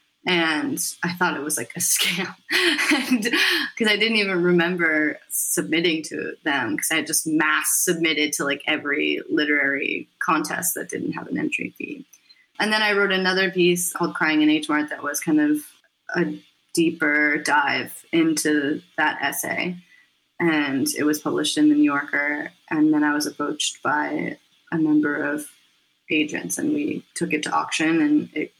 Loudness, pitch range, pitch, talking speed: -21 LUFS, 150-185 Hz, 160 Hz, 165 wpm